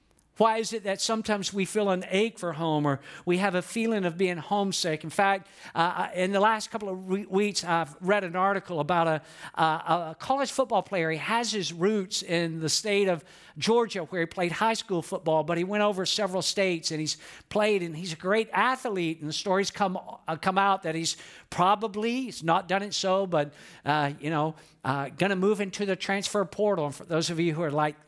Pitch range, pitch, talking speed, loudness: 165-205 Hz, 185 Hz, 220 wpm, -27 LUFS